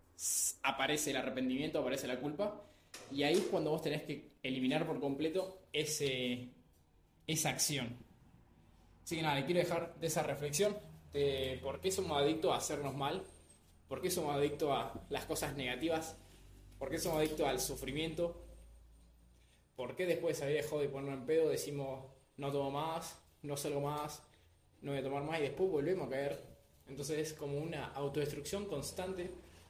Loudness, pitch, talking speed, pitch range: -38 LUFS, 145 Hz, 170 wpm, 130-160 Hz